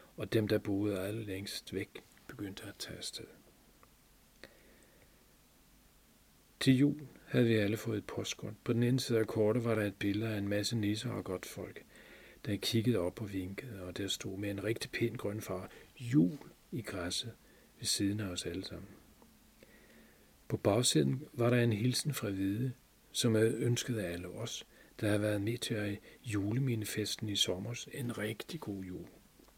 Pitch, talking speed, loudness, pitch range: 110 Hz, 175 wpm, -35 LUFS, 100-120 Hz